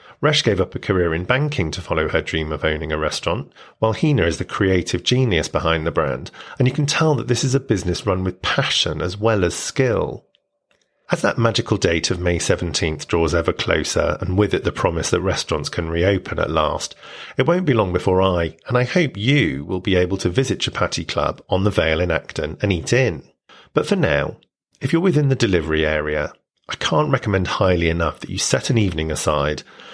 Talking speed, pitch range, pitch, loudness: 215 wpm, 85-125 Hz, 95 Hz, -20 LUFS